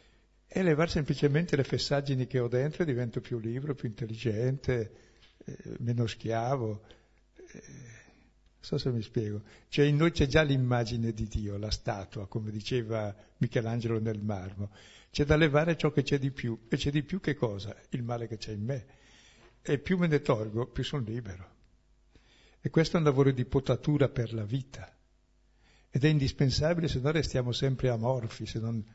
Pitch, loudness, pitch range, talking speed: 125 Hz, -30 LUFS, 110-145 Hz, 175 wpm